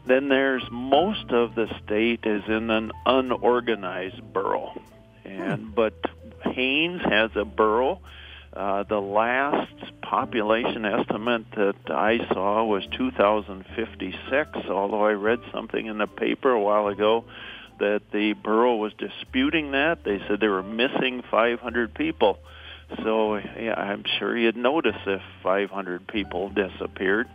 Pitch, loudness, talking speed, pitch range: 110 Hz, -25 LUFS, 130 wpm, 100-125 Hz